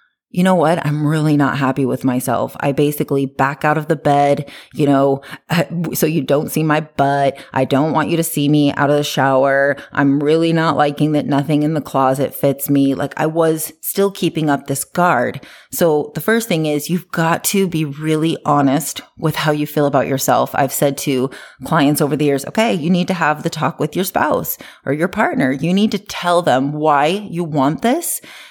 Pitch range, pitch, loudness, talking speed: 140-165 Hz, 150 Hz, -16 LUFS, 210 wpm